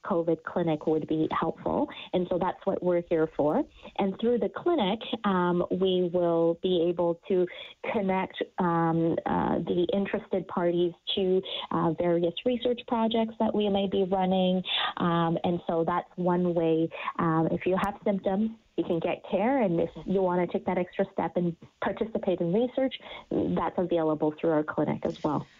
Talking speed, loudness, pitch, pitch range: 170 wpm, -28 LUFS, 180 Hz, 170-200 Hz